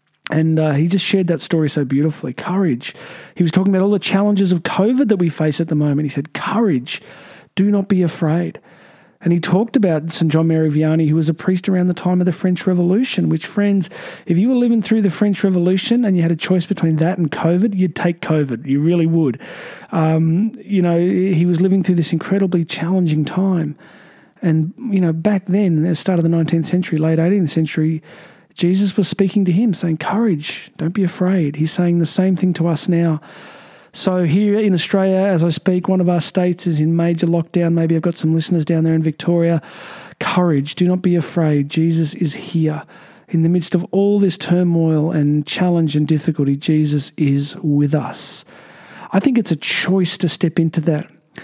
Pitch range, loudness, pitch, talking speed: 160-190 Hz, -17 LUFS, 175 Hz, 205 wpm